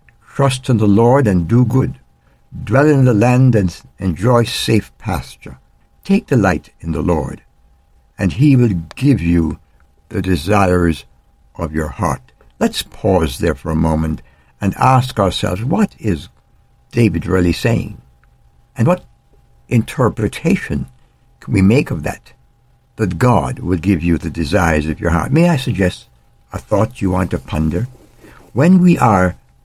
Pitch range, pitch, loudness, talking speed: 80-120 Hz, 90 Hz, -15 LUFS, 150 wpm